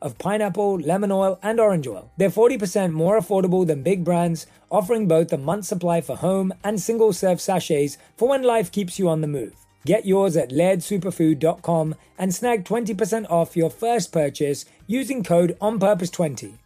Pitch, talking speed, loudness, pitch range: 185 Hz, 170 wpm, -21 LUFS, 165-210 Hz